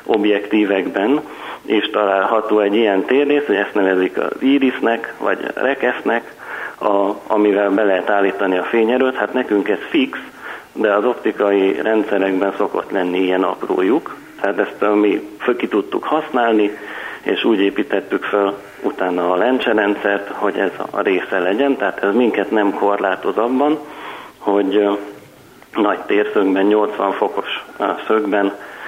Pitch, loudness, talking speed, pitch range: 100 Hz, -17 LUFS, 135 wpm, 100-110 Hz